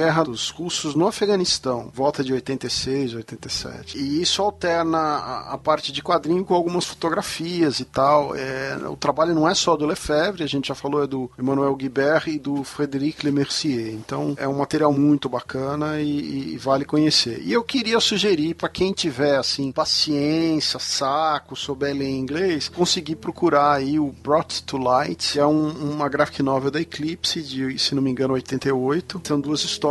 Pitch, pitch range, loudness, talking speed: 145 Hz, 135-160 Hz, -22 LUFS, 180 wpm